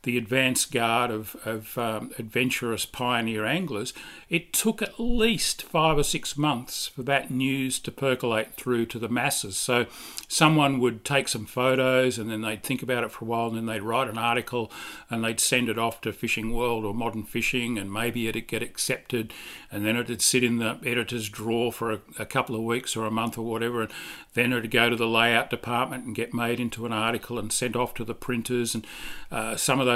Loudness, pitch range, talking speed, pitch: -26 LUFS, 115-125 Hz, 215 wpm, 120 Hz